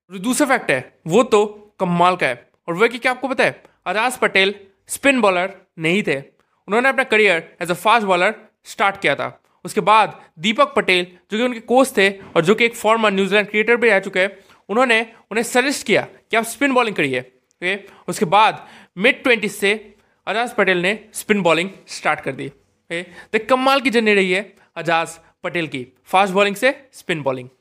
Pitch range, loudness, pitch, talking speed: 180-230 Hz, -18 LUFS, 205 Hz, 195 wpm